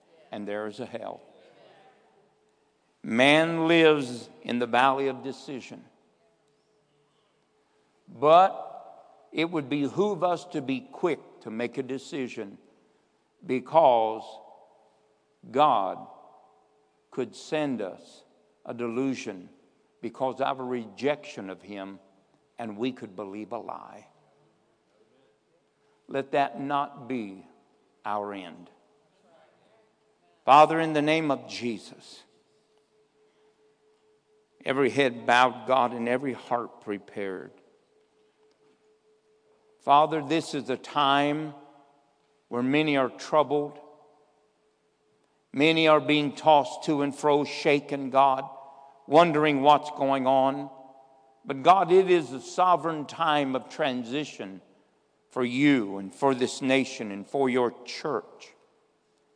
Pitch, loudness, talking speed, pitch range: 140 Hz, -25 LUFS, 105 wpm, 125-155 Hz